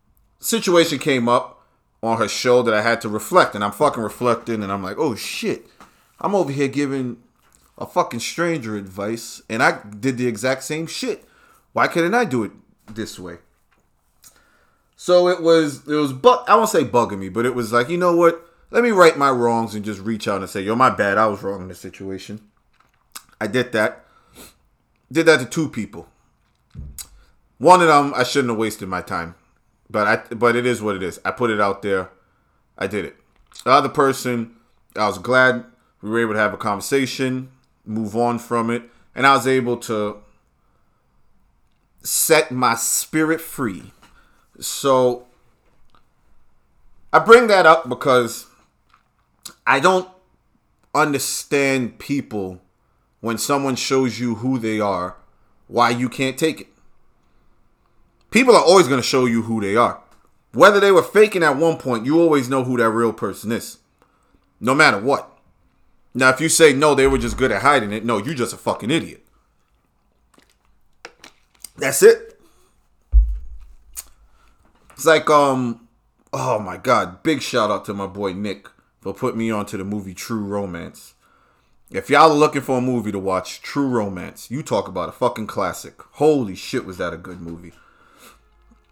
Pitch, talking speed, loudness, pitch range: 120 Hz, 170 wpm, -18 LUFS, 105-140 Hz